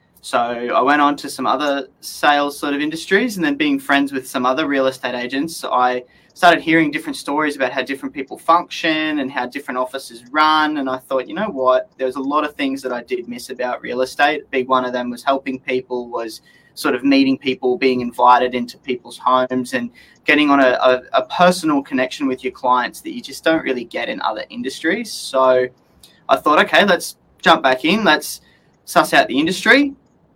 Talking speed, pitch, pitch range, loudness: 210 wpm, 135 Hz, 130-160 Hz, -17 LUFS